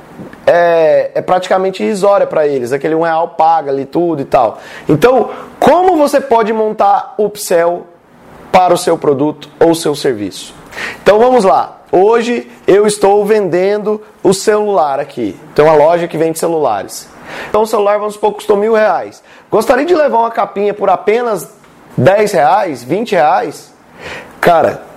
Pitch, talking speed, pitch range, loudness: 205 Hz, 155 wpm, 170-220 Hz, -11 LUFS